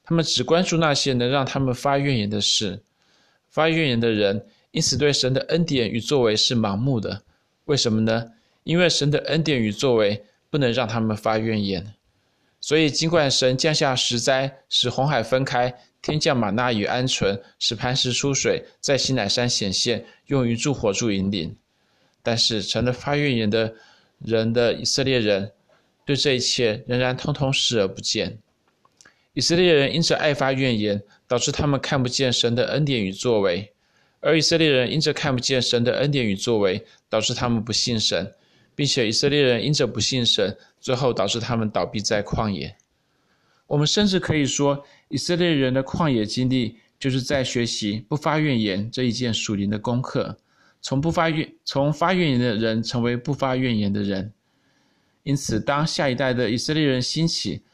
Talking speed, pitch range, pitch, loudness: 265 characters per minute, 115-145 Hz, 125 Hz, -22 LUFS